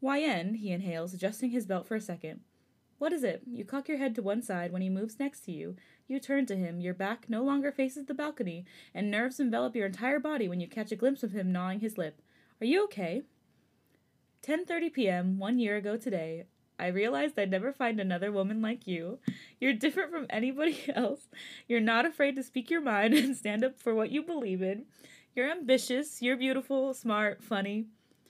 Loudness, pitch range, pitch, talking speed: -32 LUFS, 195-275 Hz, 235 Hz, 210 wpm